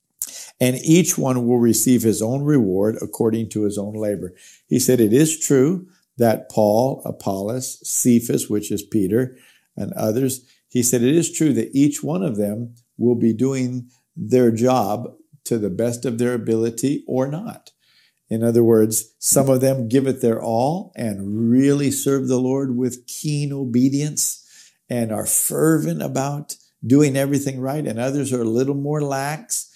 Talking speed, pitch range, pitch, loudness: 165 wpm, 115-135 Hz, 125 Hz, -19 LUFS